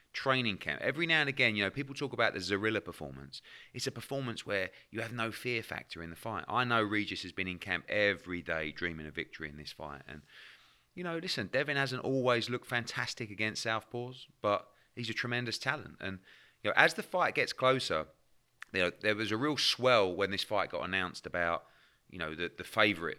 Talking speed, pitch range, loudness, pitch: 215 wpm, 95-125 Hz, -33 LUFS, 115 Hz